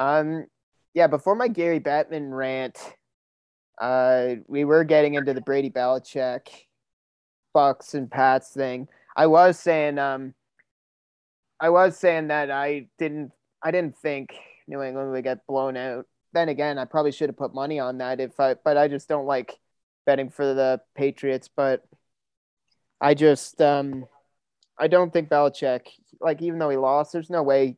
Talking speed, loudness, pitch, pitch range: 160 wpm, -23 LUFS, 140 Hz, 130-150 Hz